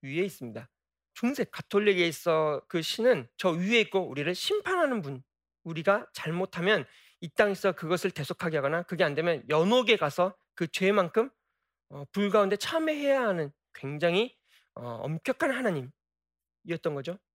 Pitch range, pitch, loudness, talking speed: 155-215 Hz, 180 Hz, -28 LUFS, 310 characters per minute